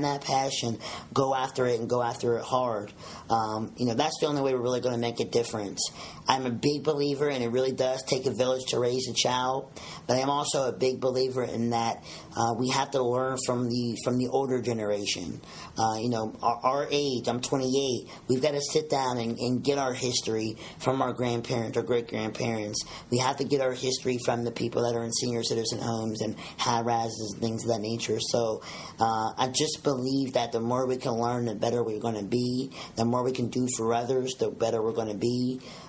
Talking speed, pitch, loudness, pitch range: 225 wpm, 125 Hz, -28 LUFS, 115-130 Hz